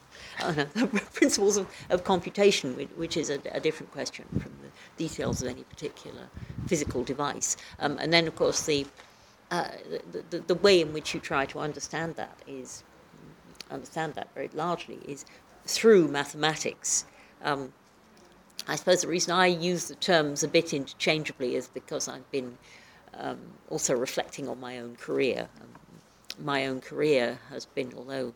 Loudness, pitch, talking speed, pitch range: -28 LUFS, 155 Hz, 165 wpm, 135-180 Hz